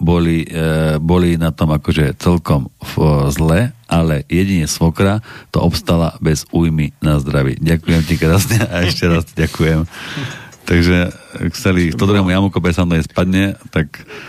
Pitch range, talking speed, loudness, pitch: 80-90 Hz, 125 wpm, -15 LUFS, 85 Hz